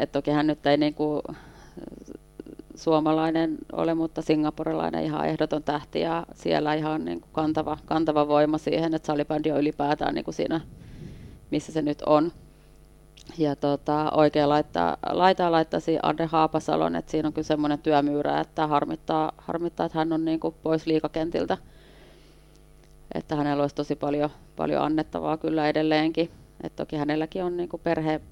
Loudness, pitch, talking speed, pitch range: -26 LUFS, 155 Hz, 145 wpm, 150-160 Hz